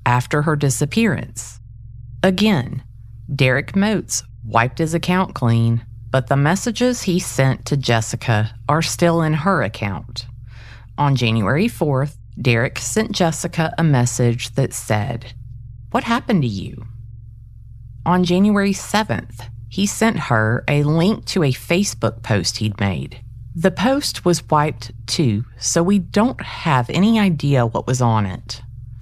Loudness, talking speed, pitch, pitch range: -19 LUFS, 135 wpm, 125 Hz, 115-170 Hz